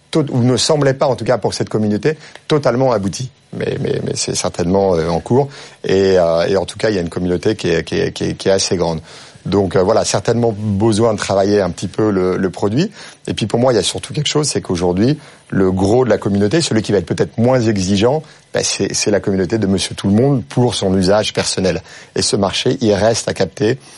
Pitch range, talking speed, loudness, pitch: 95-125 Hz, 240 wpm, -16 LUFS, 110 Hz